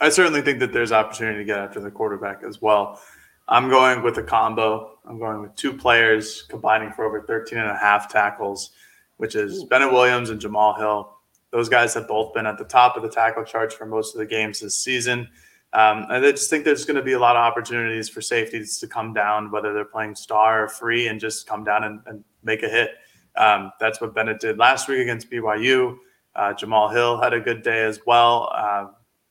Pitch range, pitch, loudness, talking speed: 110-120 Hz, 110 Hz, -20 LUFS, 225 wpm